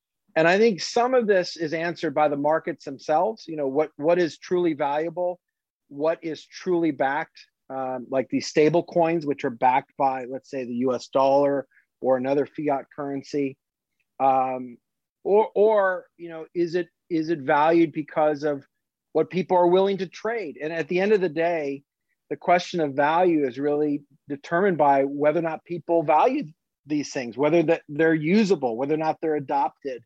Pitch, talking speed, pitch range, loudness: 155 Hz, 180 wpm, 140-170 Hz, -24 LUFS